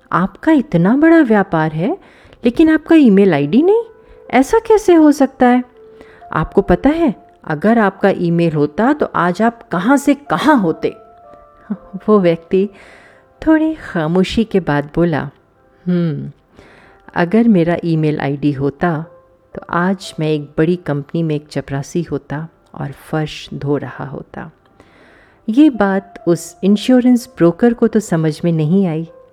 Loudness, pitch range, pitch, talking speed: -14 LUFS, 160-245 Hz, 185 Hz, 135 wpm